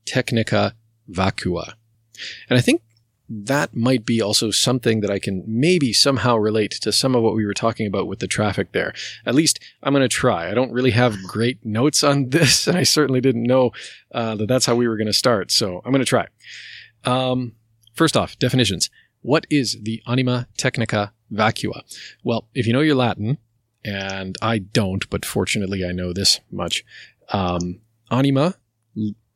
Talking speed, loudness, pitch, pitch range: 180 wpm, -20 LUFS, 115 Hz, 105-125 Hz